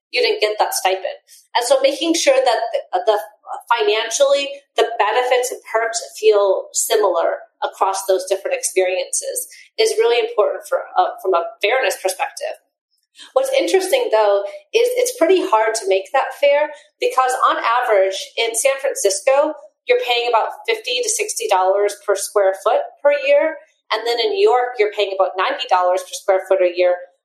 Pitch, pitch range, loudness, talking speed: 250 Hz, 200-310 Hz, -18 LUFS, 165 wpm